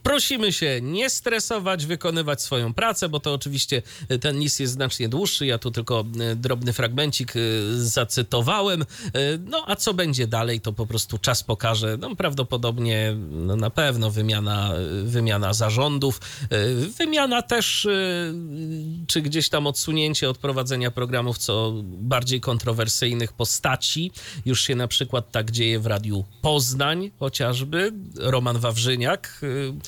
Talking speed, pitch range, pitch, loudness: 130 wpm, 115-155 Hz, 130 Hz, -23 LUFS